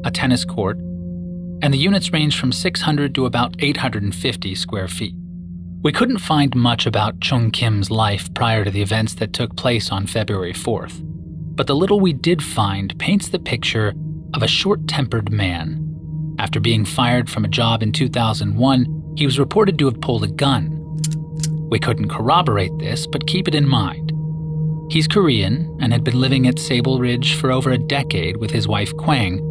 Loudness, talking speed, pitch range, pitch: -19 LUFS, 175 wpm, 110-155 Hz, 130 Hz